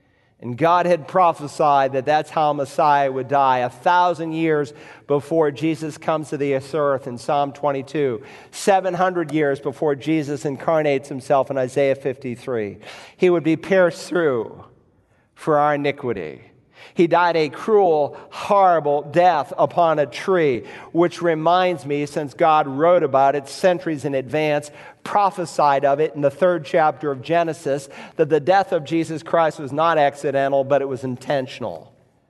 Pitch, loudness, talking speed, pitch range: 150 Hz, -20 LUFS, 150 wpm, 140-170 Hz